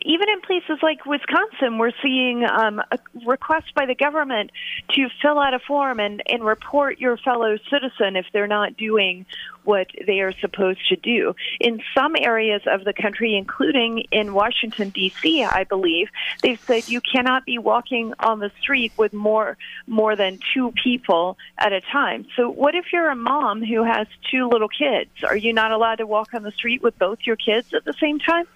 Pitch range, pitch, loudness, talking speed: 215-280 Hz, 235 Hz, -20 LUFS, 195 wpm